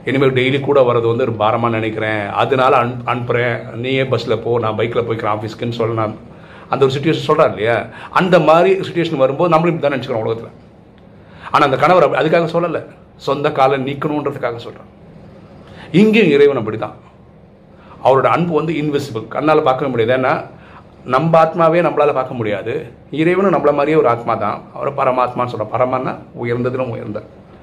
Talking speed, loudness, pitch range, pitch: 155 wpm, -15 LUFS, 120-155 Hz, 135 Hz